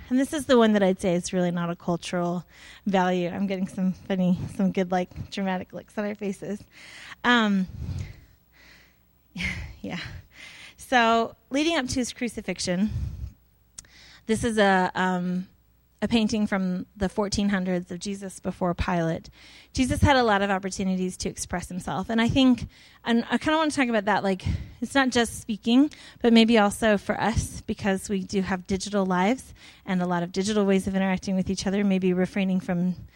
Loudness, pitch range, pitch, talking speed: -25 LUFS, 185-220 Hz, 195 Hz, 175 wpm